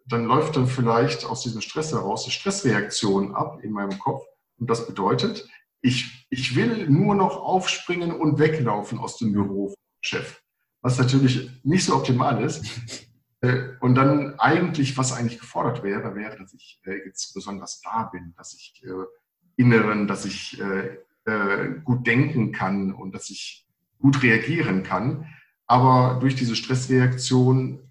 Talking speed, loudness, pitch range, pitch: 145 wpm, -23 LUFS, 105-140 Hz, 125 Hz